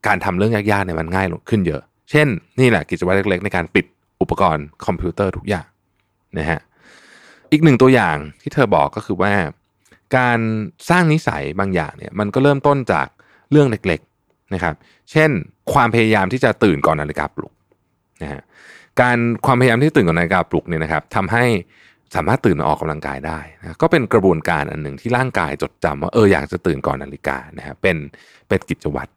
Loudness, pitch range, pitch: -18 LUFS, 80-120 Hz, 100 Hz